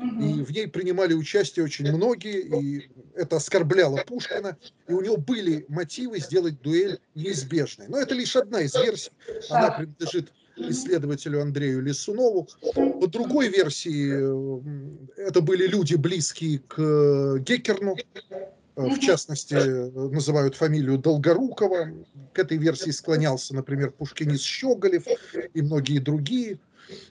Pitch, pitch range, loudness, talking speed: 160 Hz, 145-195 Hz, -25 LUFS, 120 wpm